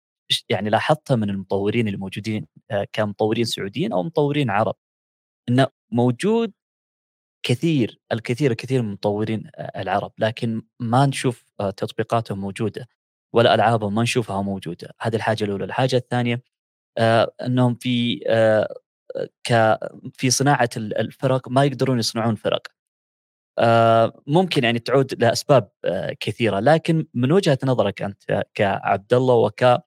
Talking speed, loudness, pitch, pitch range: 110 wpm, -21 LUFS, 120 Hz, 110-135 Hz